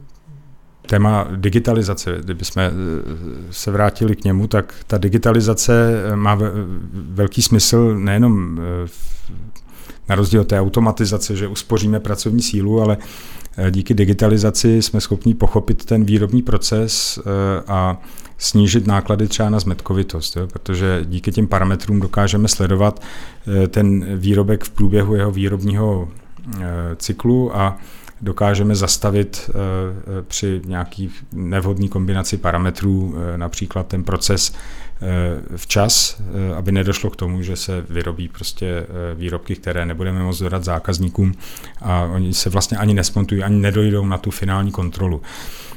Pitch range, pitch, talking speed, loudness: 90-105 Hz, 100 Hz, 125 wpm, -18 LUFS